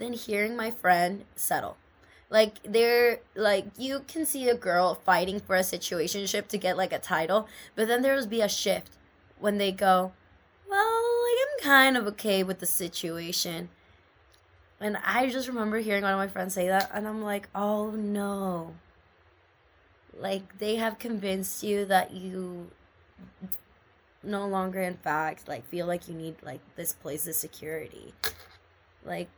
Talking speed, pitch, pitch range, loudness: 160 wpm, 195 Hz, 175-220 Hz, -28 LUFS